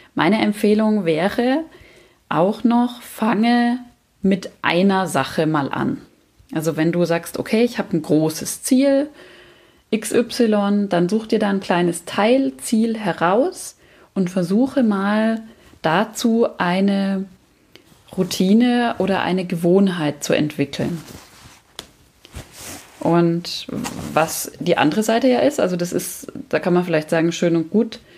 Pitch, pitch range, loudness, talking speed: 195 Hz, 170-230 Hz, -19 LUFS, 125 wpm